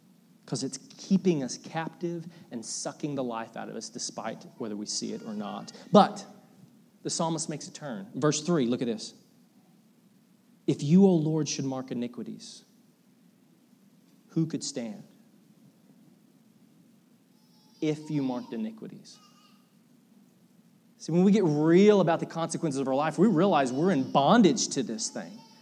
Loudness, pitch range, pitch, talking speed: -27 LUFS, 160-225 Hz, 210 Hz, 150 wpm